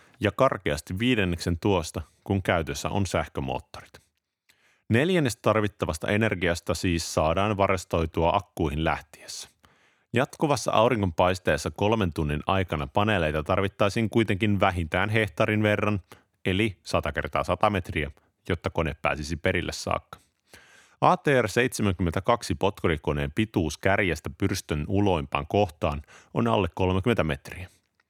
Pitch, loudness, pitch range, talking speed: 95 Hz, -26 LUFS, 85-105 Hz, 105 wpm